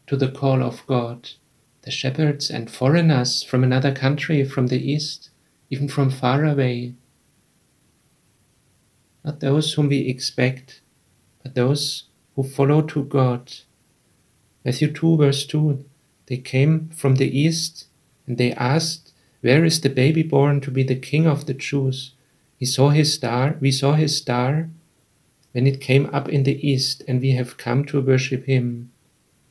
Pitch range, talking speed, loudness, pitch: 130-145 Hz, 155 wpm, -20 LUFS, 135 Hz